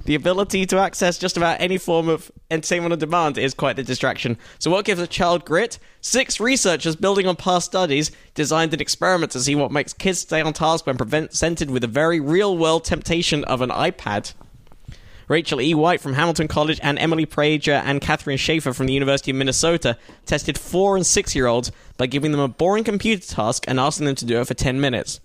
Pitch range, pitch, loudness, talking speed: 140-175 Hz, 155 Hz, -20 LUFS, 205 wpm